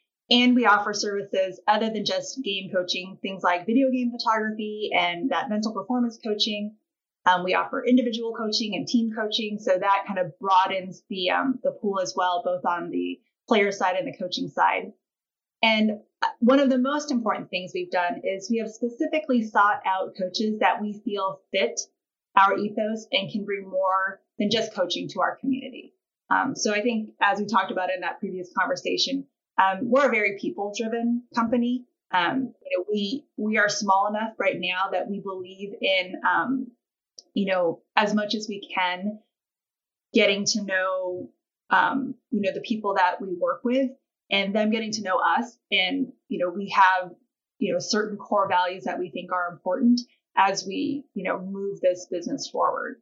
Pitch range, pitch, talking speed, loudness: 190-240 Hz, 210 Hz, 180 wpm, -25 LUFS